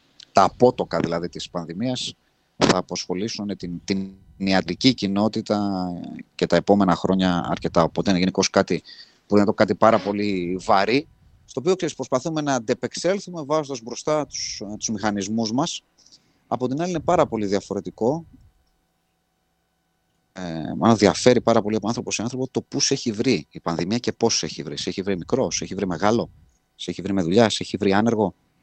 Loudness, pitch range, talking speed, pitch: -22 LUFS, 90-125 Hz, 170 wpm, 100 Hz